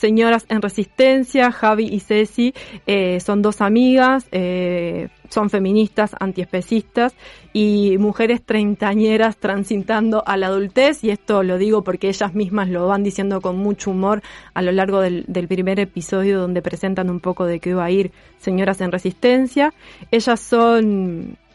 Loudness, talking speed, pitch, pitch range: -18 LUFS, 155 wpm, 205 Hz, 190-220 Hz